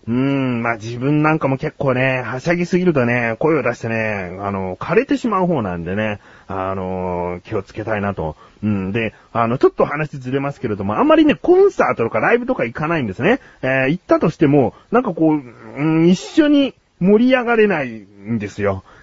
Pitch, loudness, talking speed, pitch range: 130 Hz, -18 LUFS, 390 characters per minute, 110-175 Hz